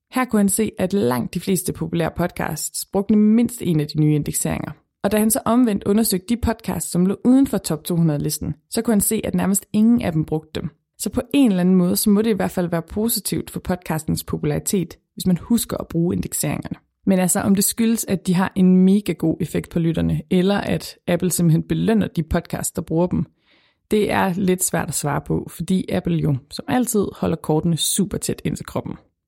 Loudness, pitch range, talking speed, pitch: -20 LUFS, 165-210 Hz, 220 wpm, 185 Hz